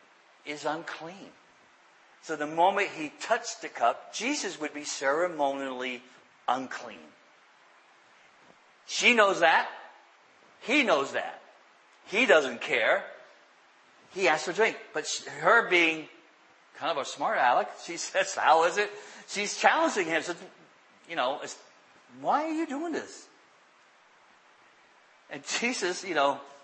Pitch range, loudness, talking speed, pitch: 150-210 Hz, -27 LUFS, 125 wpm, 170 Hz